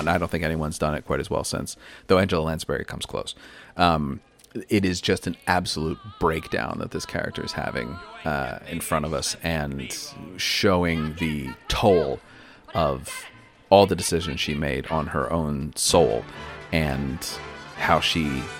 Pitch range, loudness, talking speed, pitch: 75-85 Hz, -24 LUFS, 160 wpm, 80 Hz